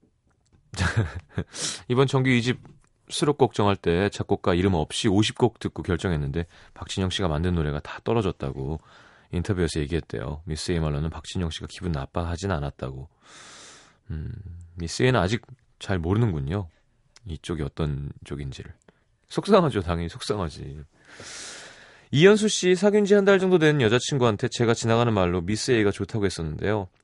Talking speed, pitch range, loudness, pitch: 325 characters per minute, 85-120 Hz, -24 LUFS, 100 Hz